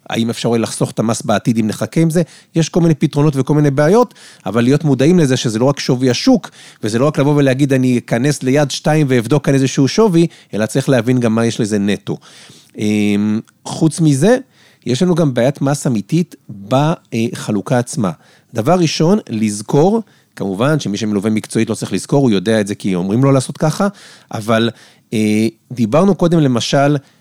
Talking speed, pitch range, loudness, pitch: 175 wpm, 115-160 Hz, -15 LUFS, 135 Hz